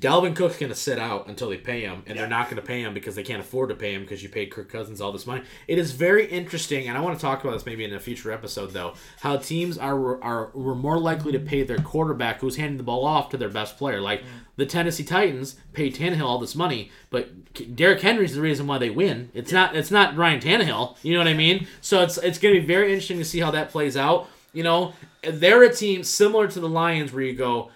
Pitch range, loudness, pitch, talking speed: 125-175 Hz, -23 LUFS, 145 Hz, 260 wpm